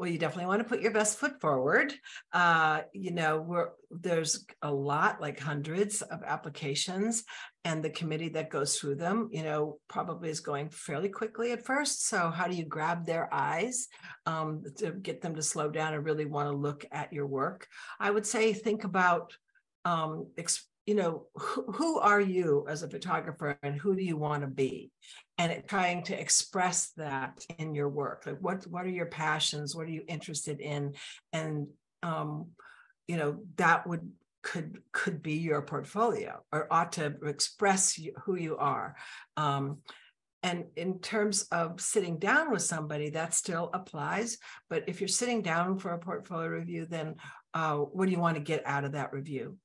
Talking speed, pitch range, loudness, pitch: 185 wpm, 150-195 Hz, -32 LUFS, 165 Hz